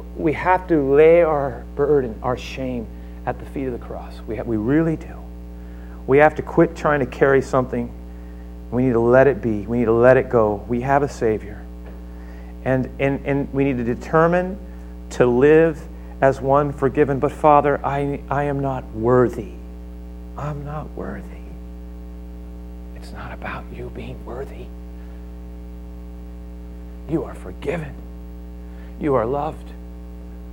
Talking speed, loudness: 150 wpm, -19 LUFS